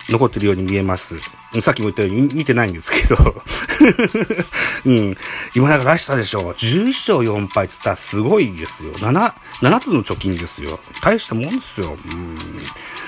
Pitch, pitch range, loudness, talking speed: 105 Hz, 95-130 Hz, -17 LUFS, 330 characters per minute